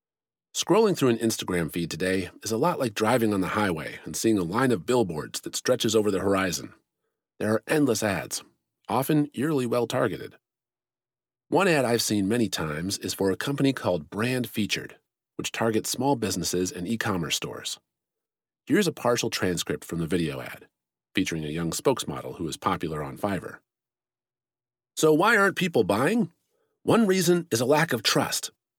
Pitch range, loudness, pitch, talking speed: 95-135 Hz, -26 LUFS, 110 Hz, 175 wpm